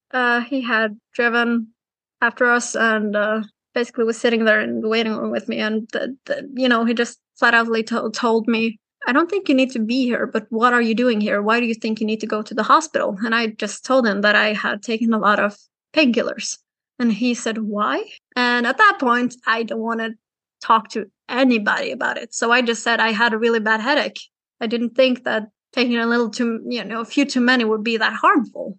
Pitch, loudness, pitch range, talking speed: 235 Hz, -19 LUFS, 220-245 Hz, 235 wpm